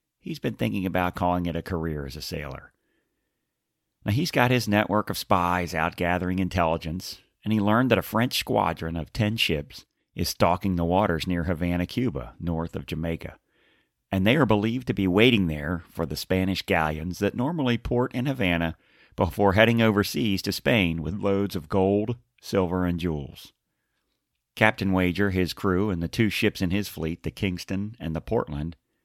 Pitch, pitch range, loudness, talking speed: 95 Hz, 85-105 Hz, -25 LUFS, 180 wpm